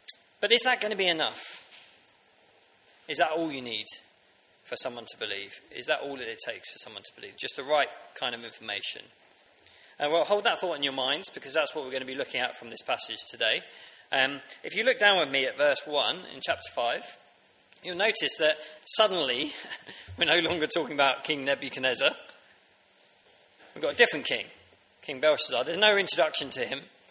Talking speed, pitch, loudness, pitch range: 195 wpm, 155 Hz, -26 LUFS, 140-205 Hz